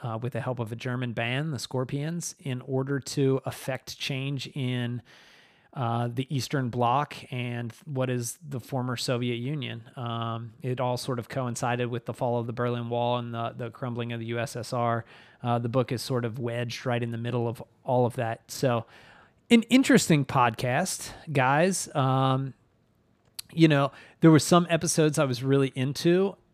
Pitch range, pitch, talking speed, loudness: 120-135 Hz, 125 Hz, 175 wpm, -27 LUFS